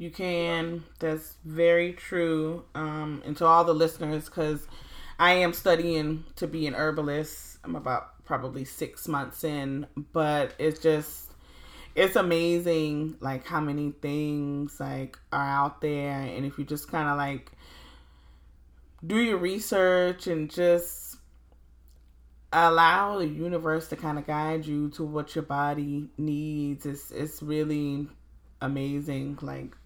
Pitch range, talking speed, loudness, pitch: 140-165 Hz, 135 wpm, -28 LUFS, 150 Hz